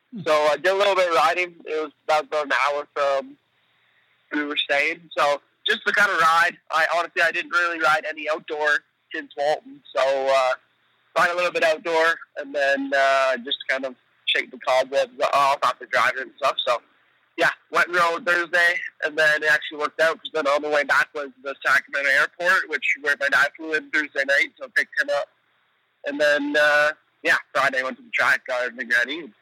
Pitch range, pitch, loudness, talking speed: 145-170 Hz, 150 Hz, -21 LUFS, 215 wpm